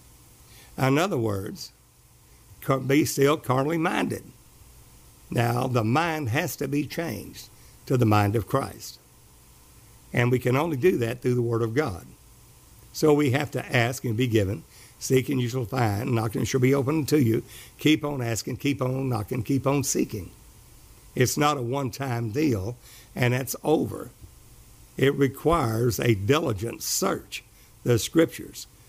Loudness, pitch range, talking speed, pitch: -25 LUFS, 115-140 Hz, 160 wpm, 125 Hz